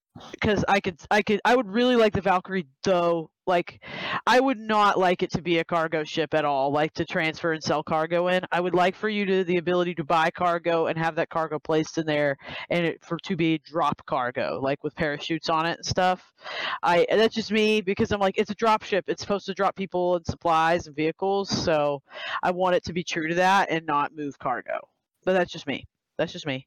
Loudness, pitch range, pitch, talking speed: -25 LUFS, 160-195 Hz, 175 Hz, 235 wpm